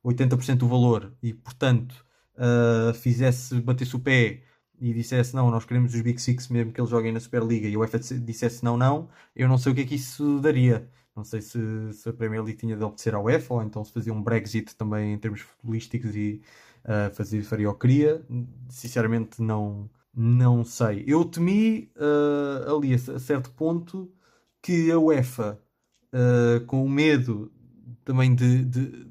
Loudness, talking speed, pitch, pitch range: -25 LUFS, 185 wpm, 120 Hz, 115-130 Hz